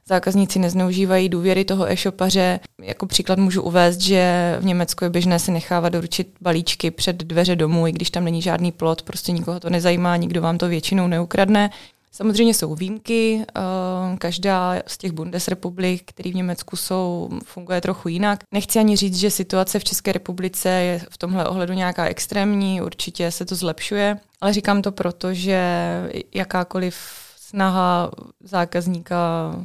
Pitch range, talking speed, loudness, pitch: 175-190 Hz, 155 wpm, -20 LUFS, 185 Hz